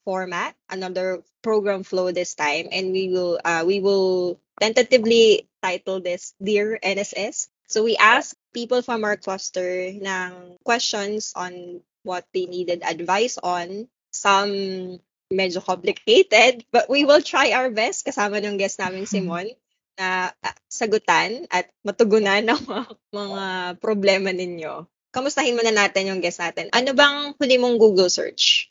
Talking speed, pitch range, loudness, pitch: 140 wpm, 185-230 Hz, -21 LUFS, 195 Hz